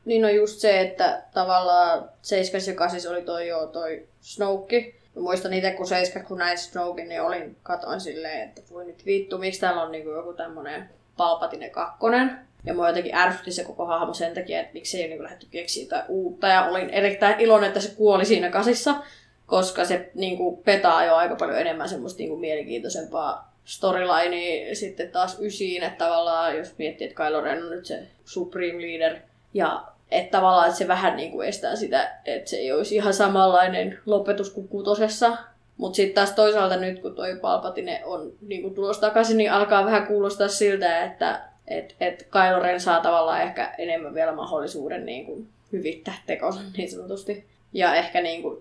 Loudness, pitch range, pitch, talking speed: -24 LUFS, 175-205 Hz, 185 Hz, 180 wpm